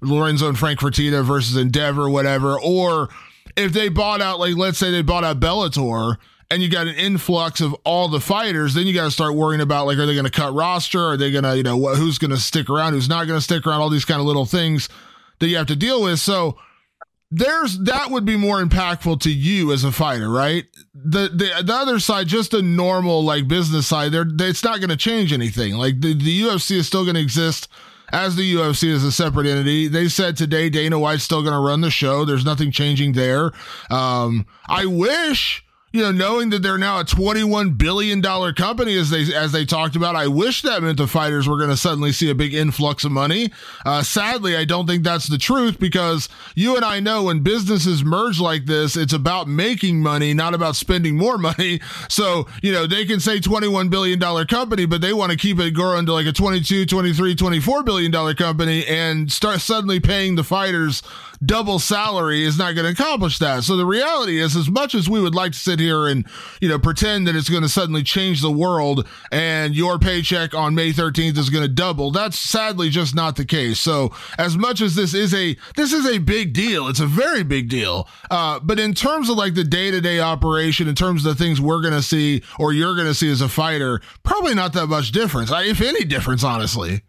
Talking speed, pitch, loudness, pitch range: 225 wpm, 165 Hz, -18 LUFS, 150-190 Hz